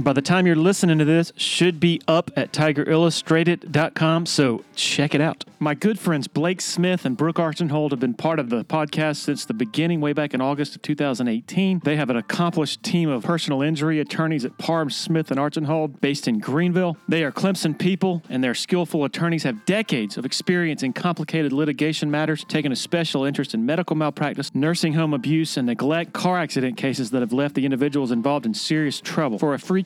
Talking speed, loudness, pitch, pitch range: 200 wpm, -22 LUFS, 155 Hz, 145-170 Hz